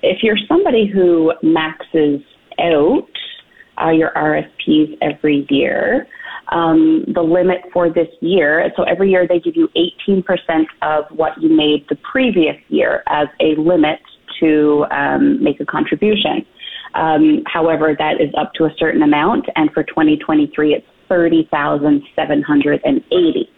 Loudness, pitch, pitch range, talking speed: -15 LUFS, 160 Hz, 150-205 Hz, 135 wpm